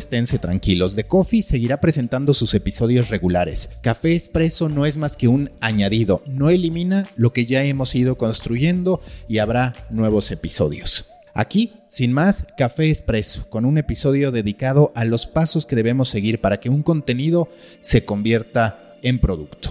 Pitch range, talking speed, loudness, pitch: 110-150 Hz, 160 wpm, -18 LUFS, 125 Hz